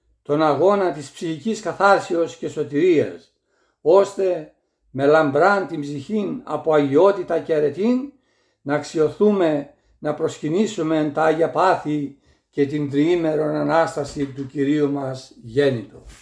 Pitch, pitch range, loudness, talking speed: 155 Hz, 145-185 Hz, -20 LUFS, 115 wpm